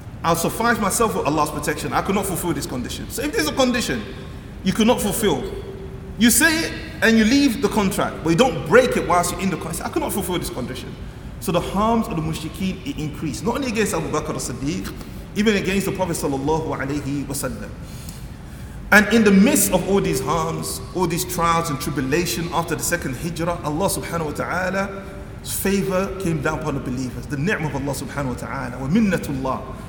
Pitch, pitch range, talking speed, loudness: 170 Hz, 145-195 Hz, 195 wpm, -21 LUFS